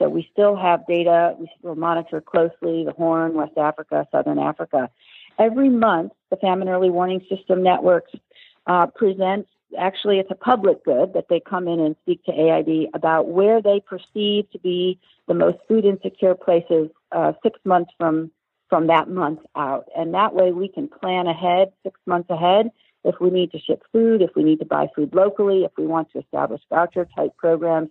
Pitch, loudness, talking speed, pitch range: 180 Hz, -20 LUFS, 190 wpm, 165-195 Hz